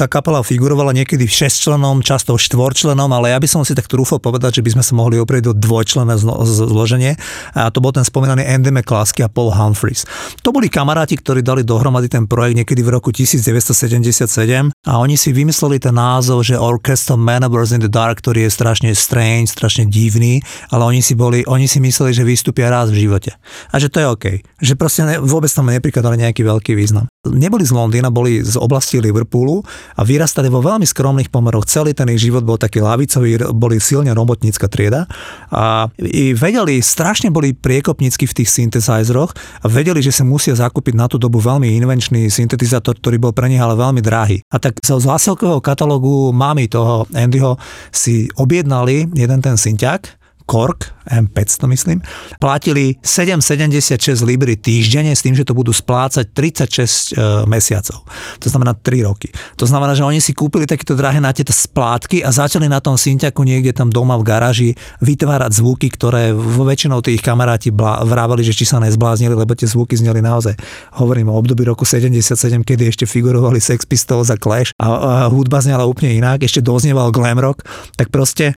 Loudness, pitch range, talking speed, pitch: -13 LUFS, 115-135 Hz, 180 wpm, 125 Hz